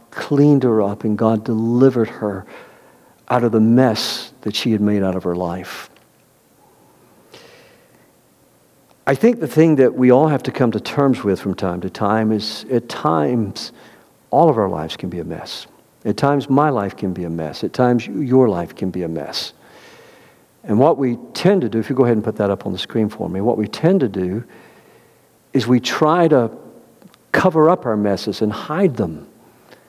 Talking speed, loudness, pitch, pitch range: 195 wpm, -18 LUFS, 115 Hz, 100-135 Hz